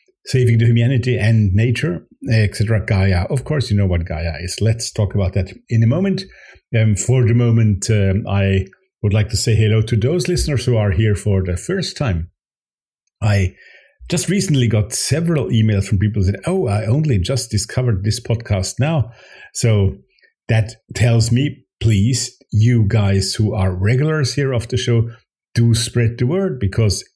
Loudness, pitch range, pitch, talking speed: -17 LUFS, 100-125 Hz, 115 Hz, 175 wpm